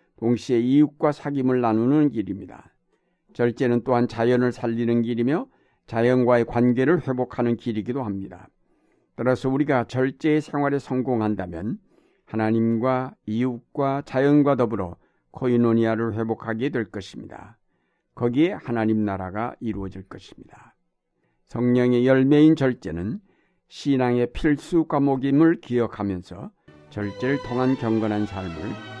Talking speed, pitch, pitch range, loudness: 295 characters per minute, 120 Hz, 110-130 Hz, -23 LUFS